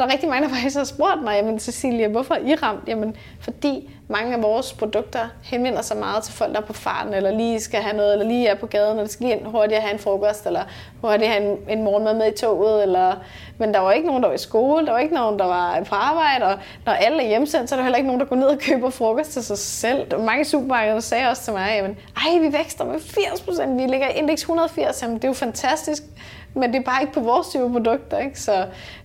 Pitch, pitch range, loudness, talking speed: 235 Hz, 215-275 Hz, -21 LUFS, 275 wpm